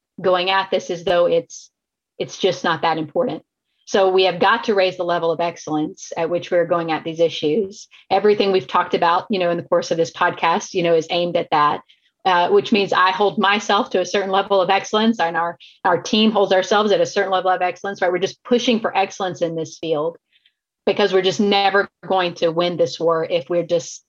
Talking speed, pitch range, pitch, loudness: 225 wpm, 170-200 Hz, 185 Hz, -19 LUFS